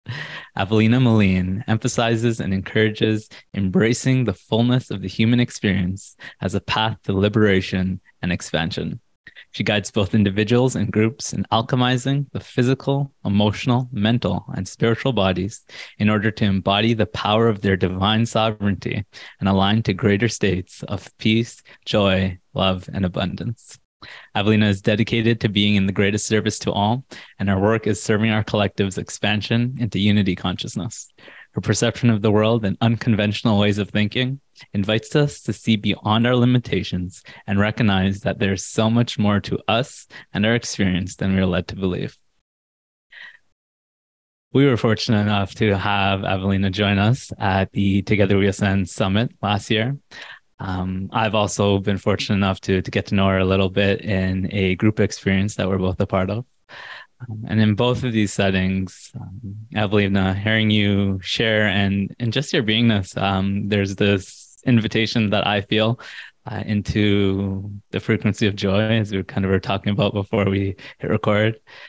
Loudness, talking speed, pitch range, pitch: -20 LUFS, 165 wpm, 100-115 Hz, 105 Hz